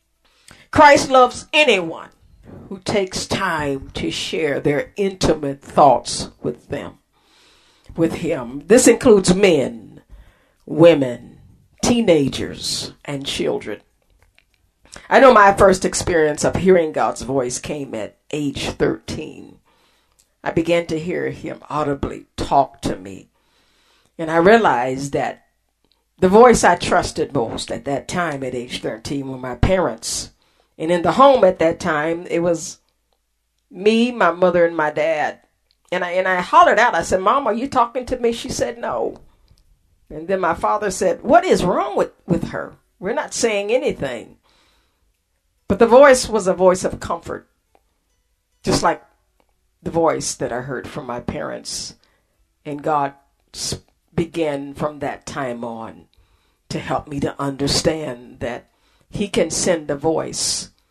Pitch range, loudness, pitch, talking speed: 140-210 Hz, -18 LUFS, 170 Hz, 145 wpm